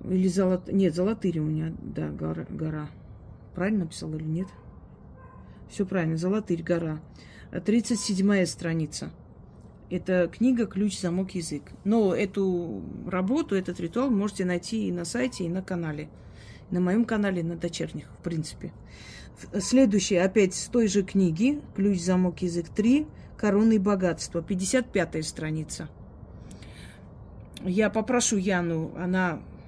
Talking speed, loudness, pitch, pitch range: 125 wpm, -27 LUFS, 180 Hz, 160-205 Hz